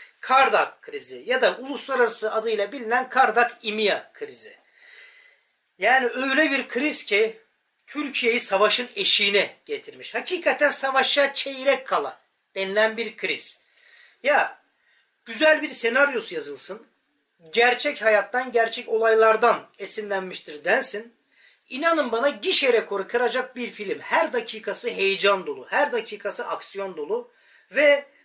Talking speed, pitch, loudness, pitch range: 115 wpm, 260 Hz, -22 LUFS, 225-370 Hz